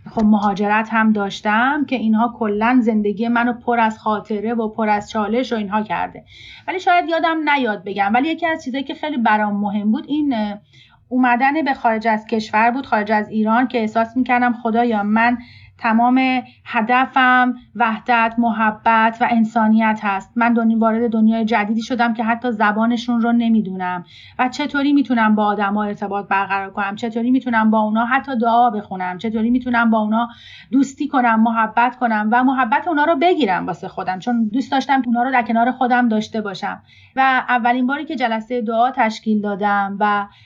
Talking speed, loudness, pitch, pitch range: 170 wpm, -18 LUFS, 230 Hz, 215-250 Hz